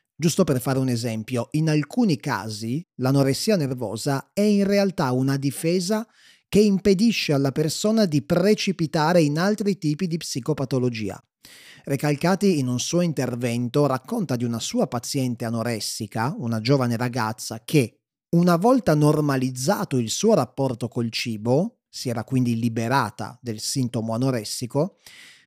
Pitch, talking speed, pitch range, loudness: 140 Hz, 130 wpm, 120-175 Hz, -23 LUFS